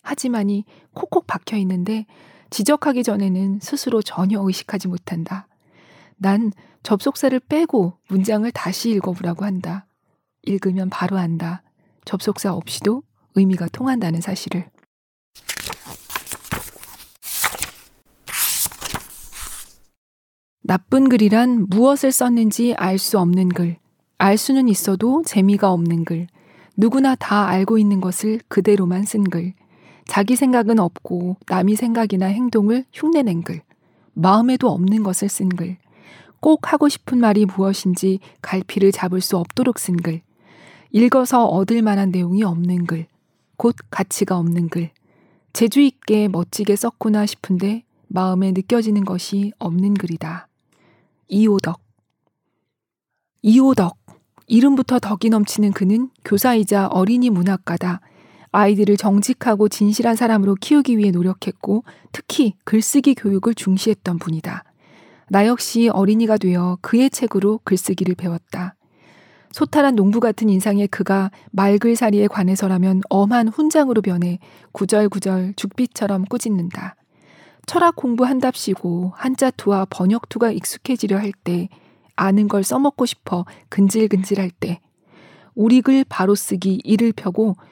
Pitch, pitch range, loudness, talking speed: 200 Hz, 185-230 Hz, -18 LUFS, 270 characters per minute